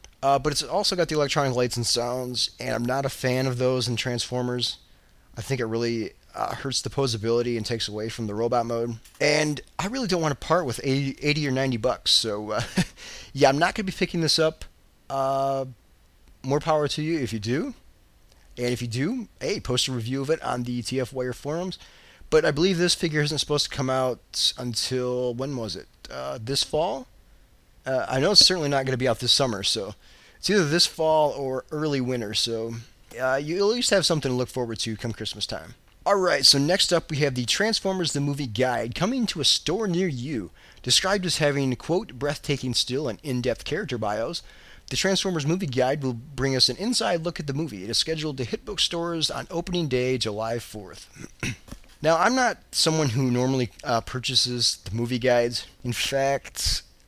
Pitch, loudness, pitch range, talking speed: 130 Hz, -24 LUFS, 120-155 Hz, 205 wpm